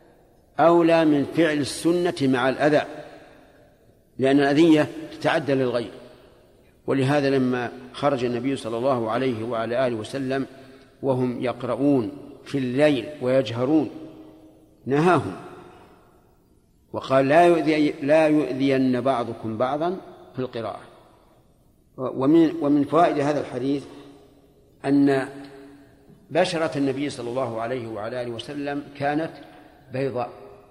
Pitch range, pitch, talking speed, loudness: 125-145 Hz, 135 Hz, 100 wpm, -22 LUFS